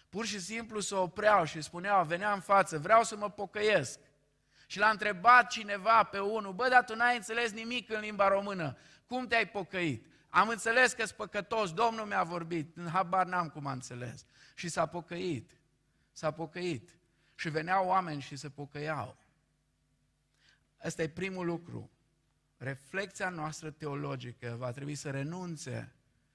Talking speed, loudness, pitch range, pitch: 155 wpm, -32 LUFS, 155-210 Hz, 180 Hz